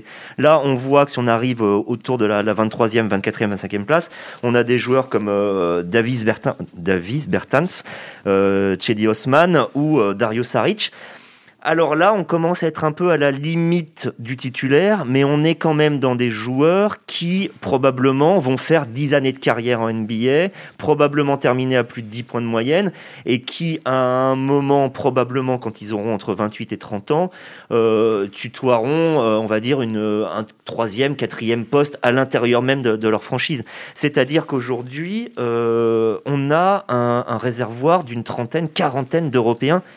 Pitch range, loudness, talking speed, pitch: 115-150 Hz, -18 LUFS, 170 wpm, 125 Hz